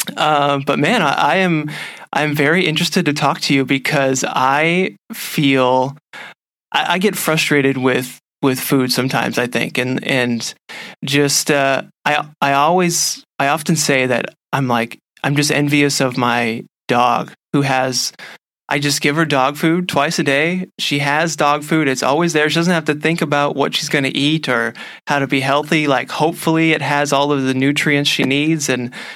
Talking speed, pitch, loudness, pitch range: 185 wpm, 145 Hz, -16 LUFS, 135-160 Hz